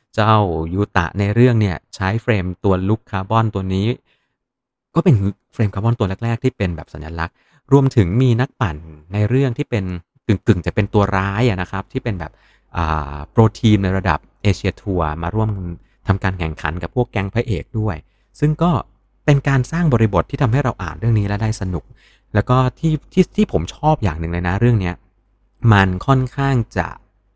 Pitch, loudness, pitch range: 105 Hz, -18 LUFS, 95-125 Hz